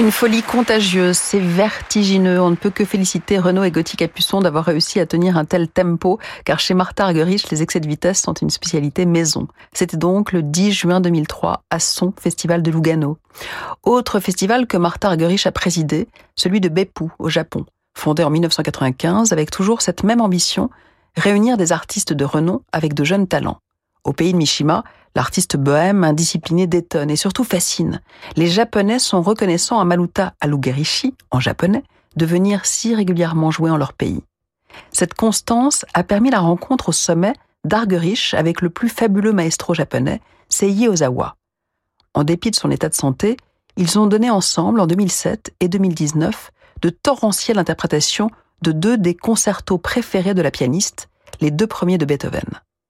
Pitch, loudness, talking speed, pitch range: 180 Hz, -17 LUFS, 170 wpm, 165-205 Hz